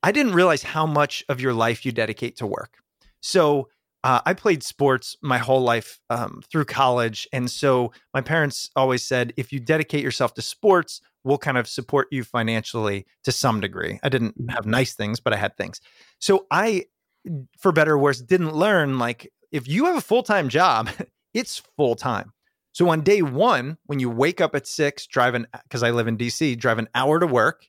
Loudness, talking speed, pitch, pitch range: -22 LUFS, 200 wpm, 135 Hz, 120-155 Hz